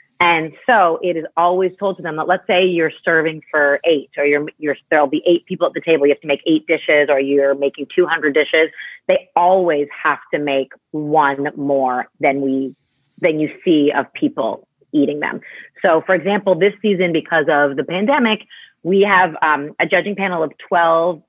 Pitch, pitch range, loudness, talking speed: 160 Hz, 145-180 Hz, -16 LUFS, 195 wpm